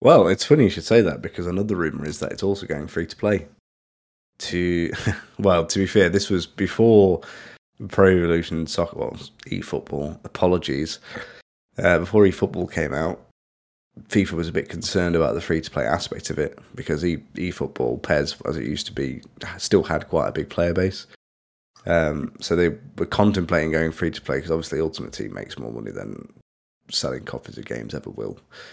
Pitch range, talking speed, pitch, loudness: 80-95 Hz, 185 wpm, 85 Hz, -22 LUFS